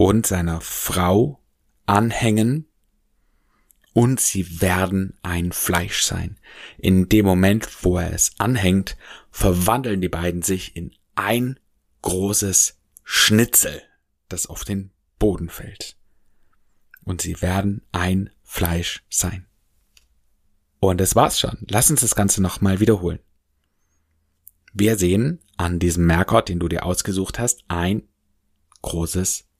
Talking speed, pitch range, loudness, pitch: 120 wpm, 85-105 Hz, -20 LUFS, 95 Hz